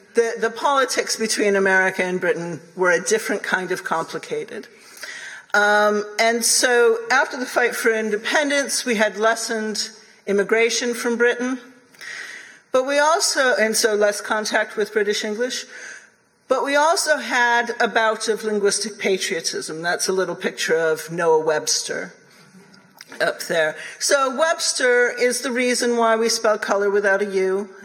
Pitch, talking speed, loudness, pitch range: 220 Hz, 145 wpm, -20 LUFS, 200-245 Hz